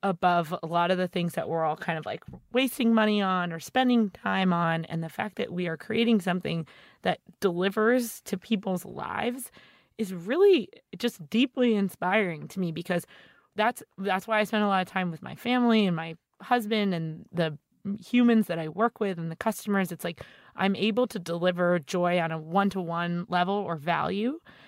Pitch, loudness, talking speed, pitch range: 190 Hz, -27 LUFS, 195 wpm, 170-220 Hz